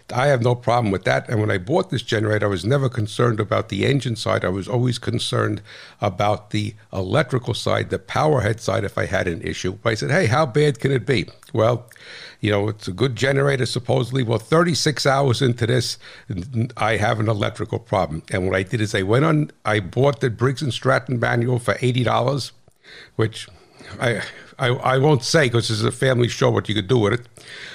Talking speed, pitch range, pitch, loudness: 215 wpm, 105-130 Hz, 120 Hz, -21 LUFS